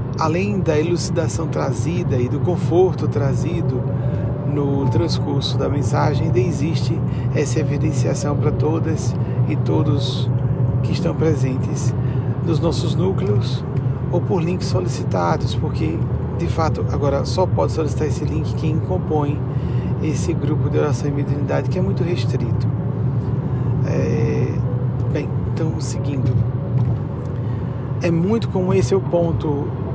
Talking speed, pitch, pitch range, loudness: 125 wpm, 130 Hz, 125-140 Hz, -20 LUFS